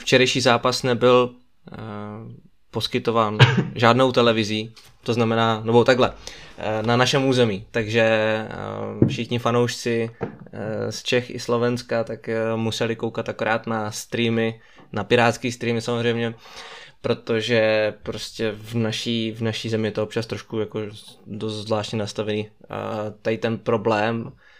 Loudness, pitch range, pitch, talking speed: -22 LUFS, 110-120 Hz, 115 Hz, 130 wpm